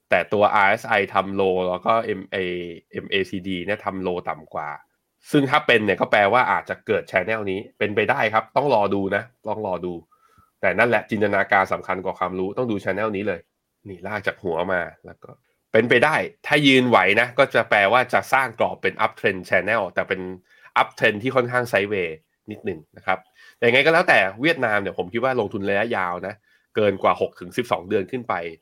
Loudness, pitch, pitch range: -21 LUFS, 100 Hz, 90-125 Hz